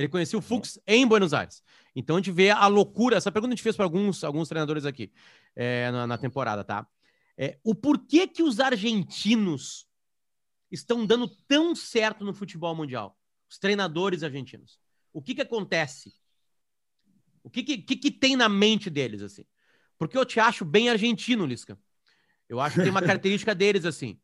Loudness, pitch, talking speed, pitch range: -25 LUFS, 195 Hz, 180 wpm, 150-225 Hz